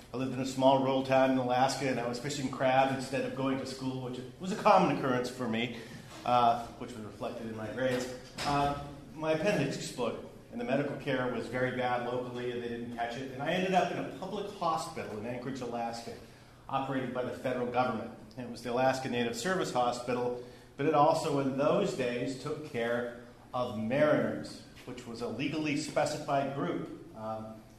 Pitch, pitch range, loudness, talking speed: 125 Hz, 120-140 Hz, -32 LUFS, 195 wpm